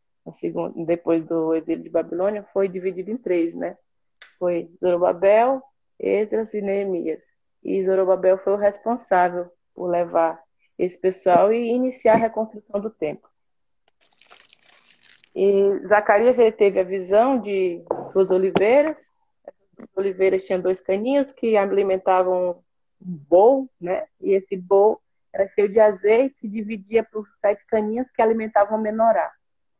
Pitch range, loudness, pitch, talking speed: 185-220 Hz, -21 LUFS, 200 Hz, 130 wpm